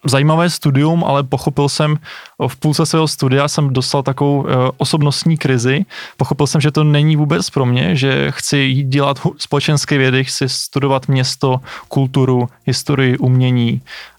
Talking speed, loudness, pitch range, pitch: 140 wpm, -15 LUFS, 130-150 Hz, 140 Hz